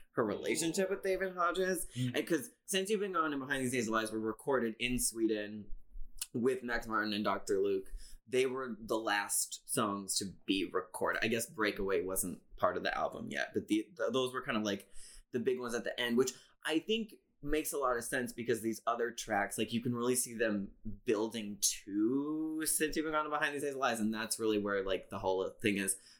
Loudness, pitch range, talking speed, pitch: -35 LUFS, 110-155 Hz, 220 wpm, 125 Hz